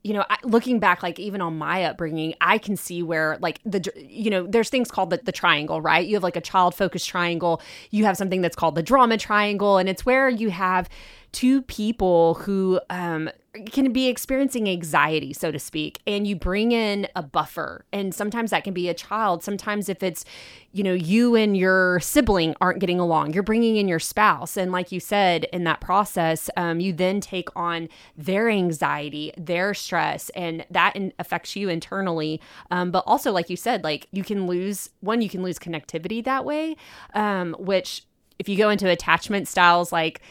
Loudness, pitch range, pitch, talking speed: -23 LUFS, 175-210 Hz, 185 Hz, 200 wpm